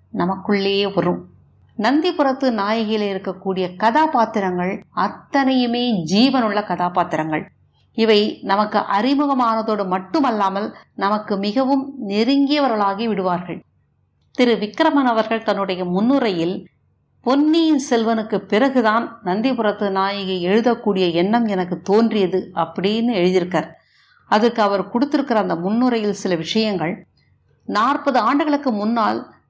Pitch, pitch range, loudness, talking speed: 210 Hz, 190-245 Hz, -19 LUFS, 85 wpm